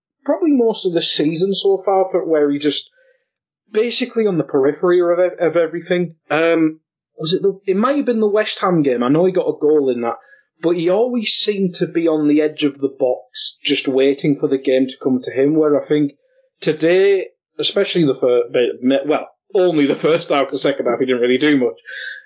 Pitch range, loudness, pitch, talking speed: 150-240 Hz, -17 LUFS, 180 Hz, 210 wpm